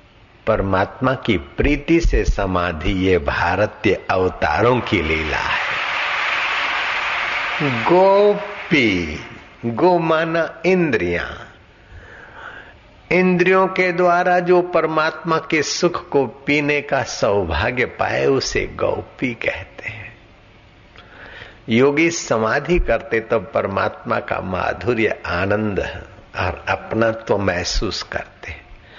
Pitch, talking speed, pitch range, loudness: 130 Hz, 90 wpm, 105-170 Hz, -18 LUFS